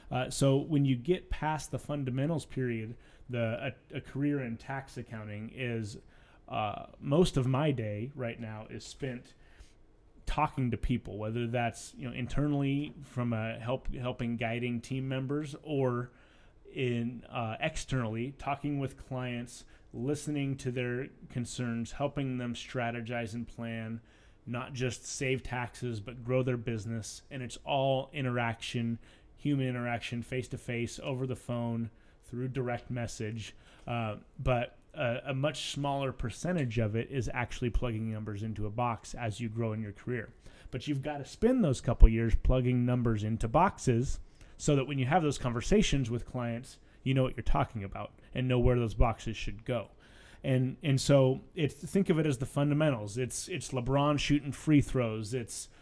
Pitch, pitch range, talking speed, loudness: 125 Hz, 115-135 Hz, 165 wpm, -33 LUFS